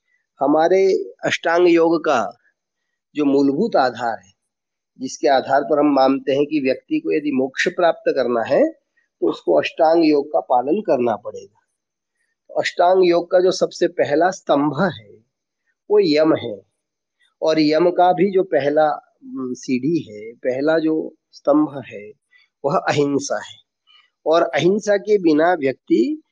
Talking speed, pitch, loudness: 140 wpm, 175 Hz, -18 LUFS